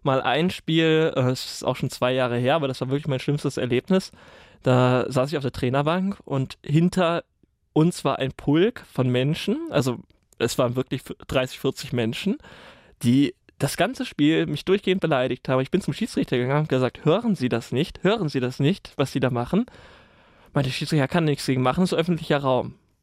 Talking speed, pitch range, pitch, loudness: 195 wpm, 130-165 Hz, 140 Hz, -23 LUFS